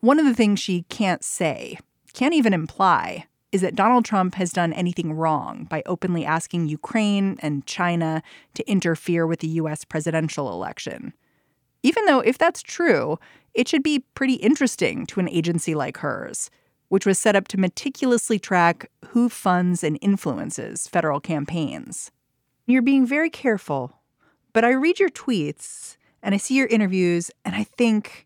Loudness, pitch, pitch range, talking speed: -22 LUFS, 195 Hz, 165-240 Hz, 160 wpm